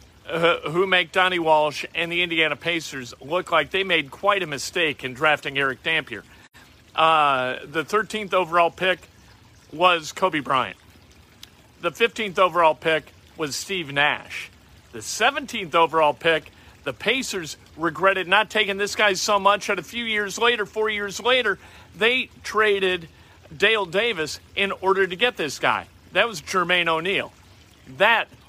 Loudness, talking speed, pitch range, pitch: -22 LUFS, 150 wpm, 155-205 Hz, 175 Hz